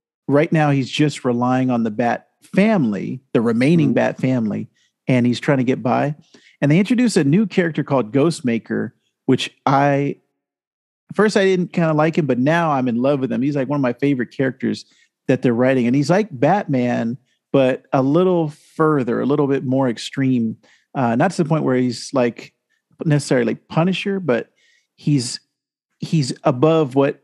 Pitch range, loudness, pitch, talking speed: 130-165 Hz, -18 LUFS, 140 Hz, 180 wpm